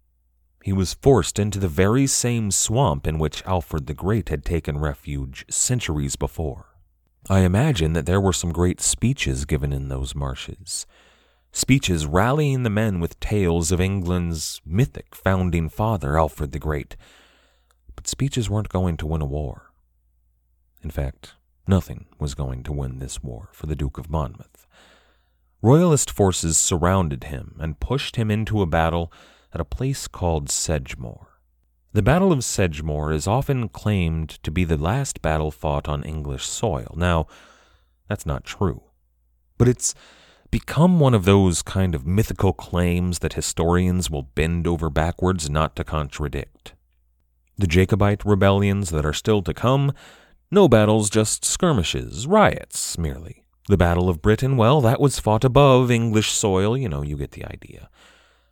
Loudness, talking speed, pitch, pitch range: -21 LUFS, 155 wpm, 85 Hz, 75-105 Hz